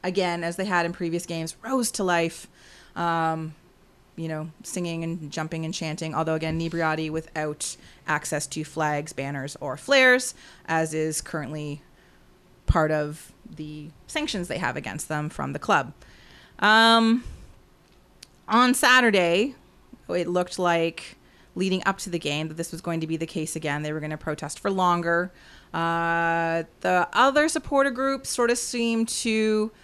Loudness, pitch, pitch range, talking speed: -25 LUFS, 165 Hz, 155-195 Hz, 155 wpm